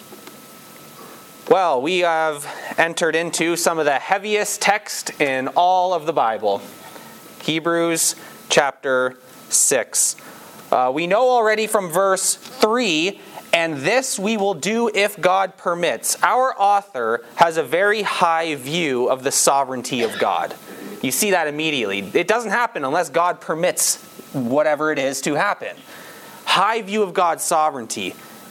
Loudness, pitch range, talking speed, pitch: -19 LUFS, 150-200 Hz, 135 wpm, 170 Hz